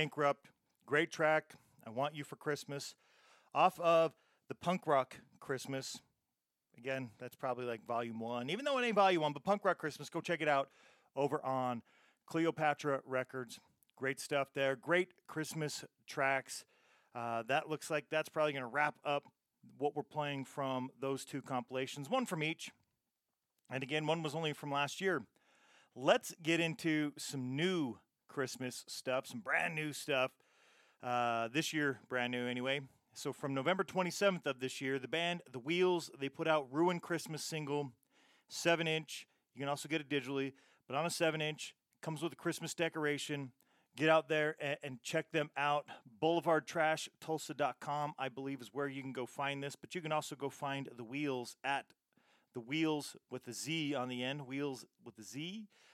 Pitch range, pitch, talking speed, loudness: 135-160 Hz, 145 Hz, 175 wpm, -38 LUFS